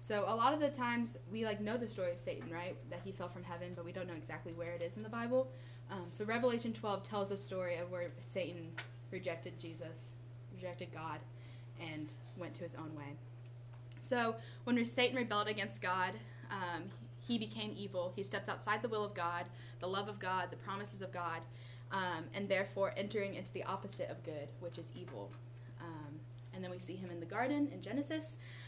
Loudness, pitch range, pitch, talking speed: -41 LUFS, 120-200 Hz, 150 Hz, 205 wpm